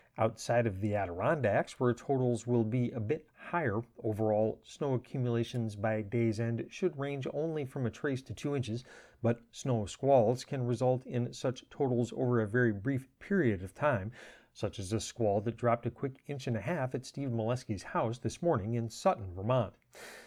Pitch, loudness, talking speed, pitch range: 120 Hz, -33 LUFS, 185 wpm, 115-135 Hz